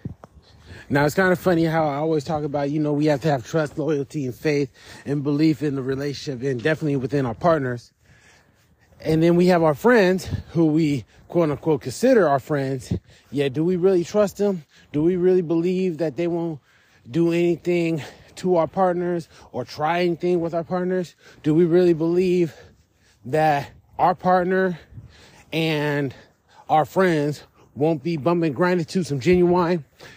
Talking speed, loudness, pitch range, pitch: 165 wpm, -22 LUFS, 140-175 Hz, 155 Hz